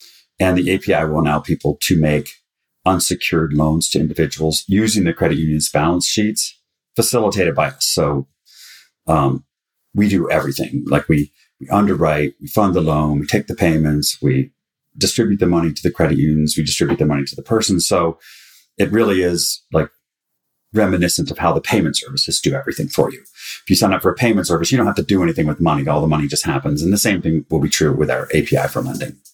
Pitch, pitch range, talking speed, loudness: 80 Hz, 75-95 Hz, 205 wpm, -17 LUFS